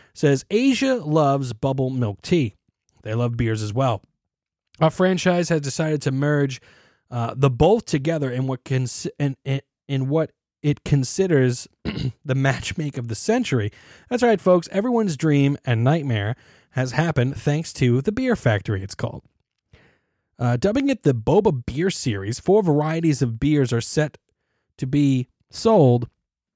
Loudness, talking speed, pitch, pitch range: -22 LUFS, 150 wpm, 140 Hz, 125-160 Hz